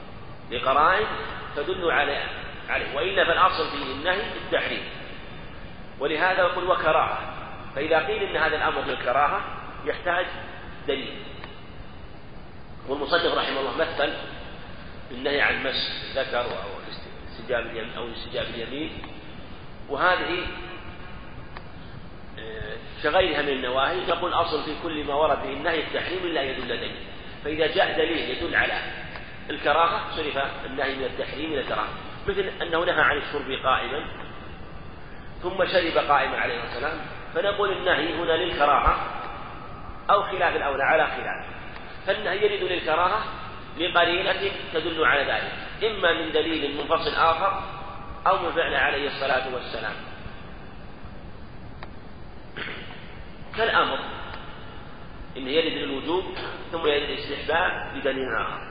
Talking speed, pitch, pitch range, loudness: 110 wpm, 180 Hz, 165-205 Hz, -25 LUFS